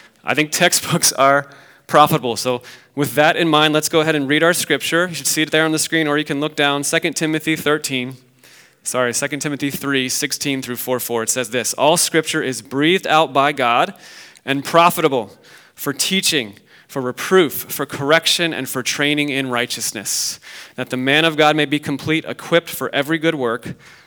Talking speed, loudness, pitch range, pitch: 190 wpm, -17 LUFS, 130-160 Hz, 145 Hz